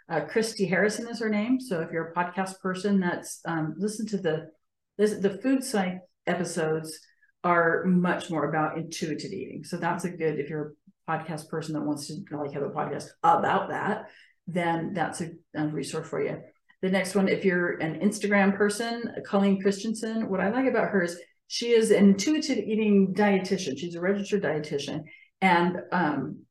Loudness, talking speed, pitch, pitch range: -27 LUFS, 185 wpm, 185 Hz, 160-210 Hz